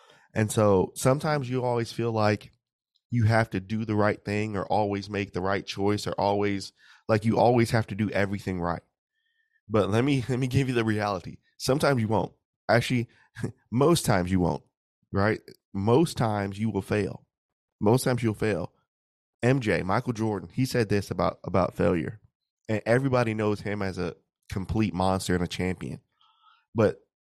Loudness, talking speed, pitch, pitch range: -27 LUFS, 170 wpm, 110 Hz, 100-125 Hz